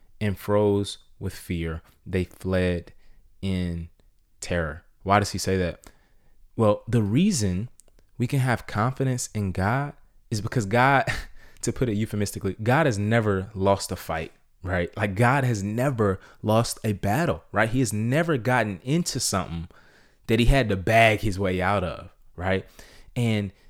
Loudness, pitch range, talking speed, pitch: -25 LUFS, 95-120 Hz, 155 wpm, 105 Hz